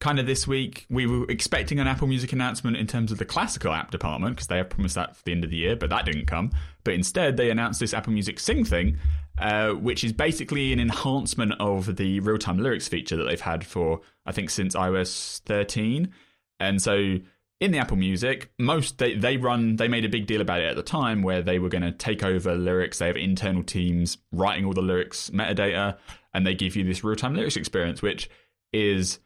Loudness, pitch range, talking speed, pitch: -26 LUFS, 90-120 Hz, 225 wpm, 100 Hz